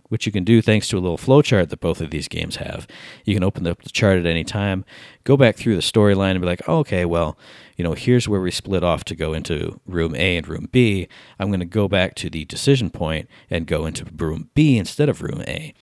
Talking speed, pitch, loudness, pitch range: 255 wpm, 95 Hz, -20 LUFS, 85-110 Hz